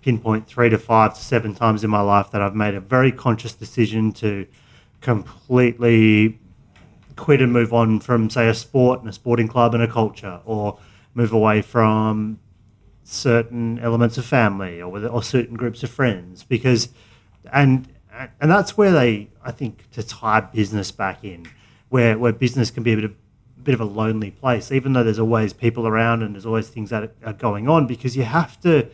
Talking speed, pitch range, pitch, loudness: 195 wpm, 110-125 Hz, 115 Hz, -19 LUFS